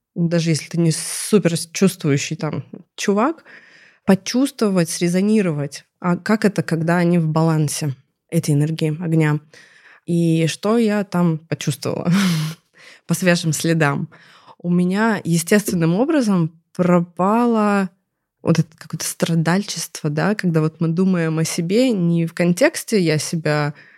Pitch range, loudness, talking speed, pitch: 160-190 Hz, -19 LUFS, 125 wpm, 170 Hz